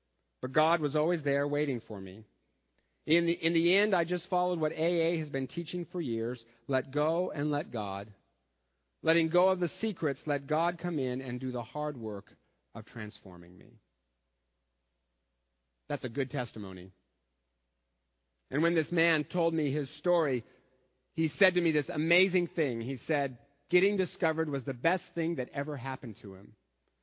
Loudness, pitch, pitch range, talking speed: -31 LUFS, 140 Hz, 100-165 Hz, 170 wpm